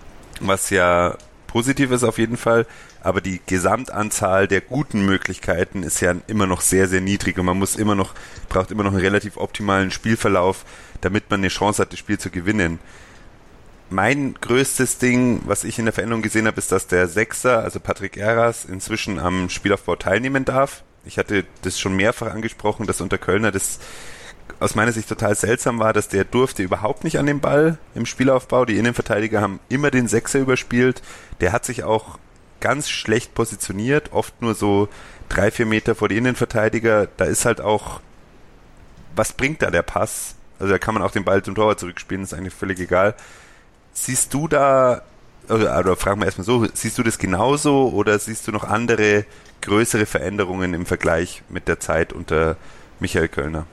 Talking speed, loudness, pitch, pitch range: 180 wpm, -20 LUFS, 105 Hz, 95-115 Hz